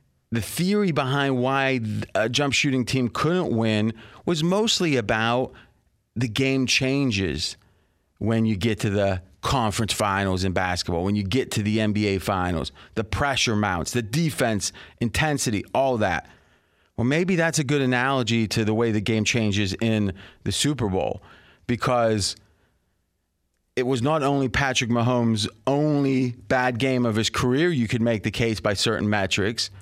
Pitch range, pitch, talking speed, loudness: 105-130 Hz, 115 Hz, 155 wpm, -23 LUFS